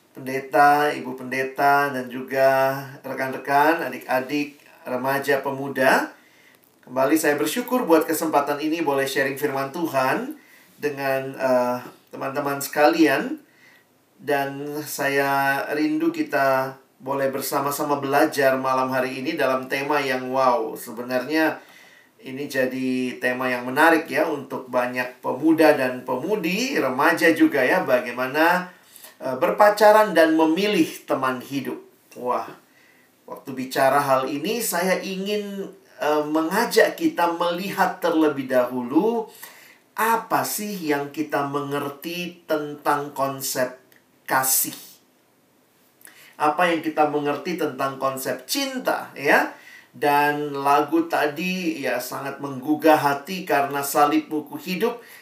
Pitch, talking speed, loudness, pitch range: 145 Hz, 105 wpm, -22 LUFS, 135-160 Hz